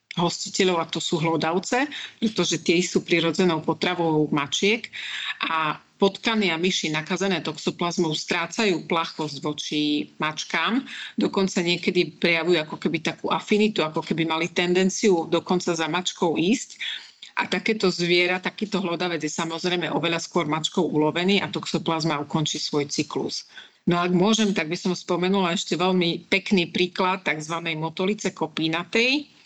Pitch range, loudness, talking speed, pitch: 165-190 Hz, -24 LUFS, 135 wpm, 175 Hz